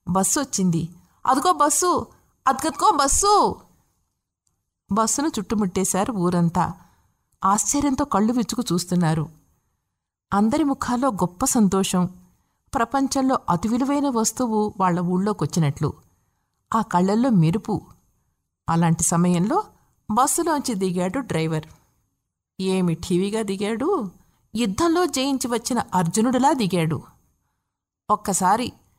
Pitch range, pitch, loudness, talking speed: 180-265 Hz, 210 Hz, -22 LUFS, 85 wpm